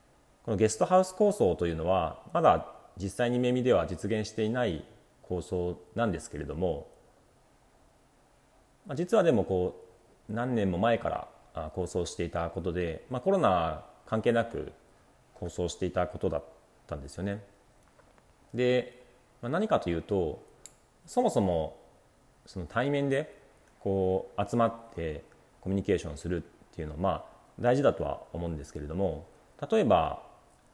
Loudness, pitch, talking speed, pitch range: -30 LUFS, 95 Hz, 280 characters per minute, 85-115 Hz